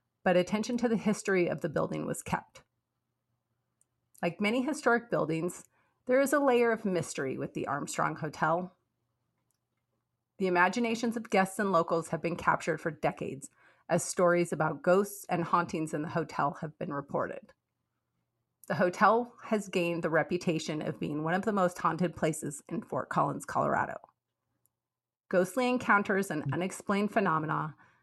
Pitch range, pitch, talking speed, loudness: 160-205 Hz, 180 Hz, 150 wpm, -31 LUFS